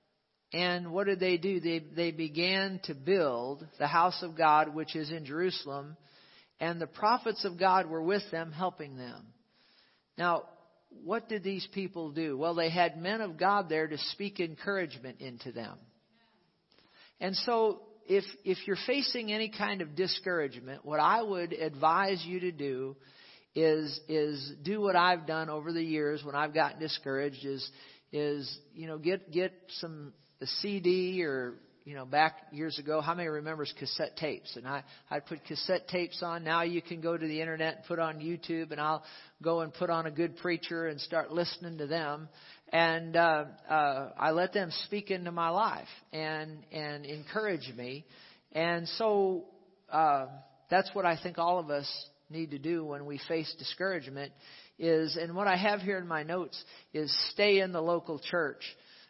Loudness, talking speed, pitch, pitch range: -32 LUFS, 175 wpm, 165 Hz, 150-180 Hz